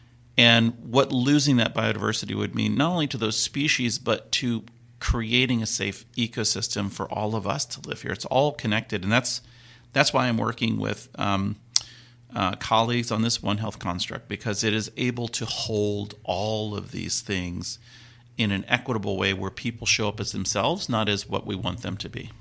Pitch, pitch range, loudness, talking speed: 115 Hz, 105-120 Hz, -25 LUFS, 190 wpm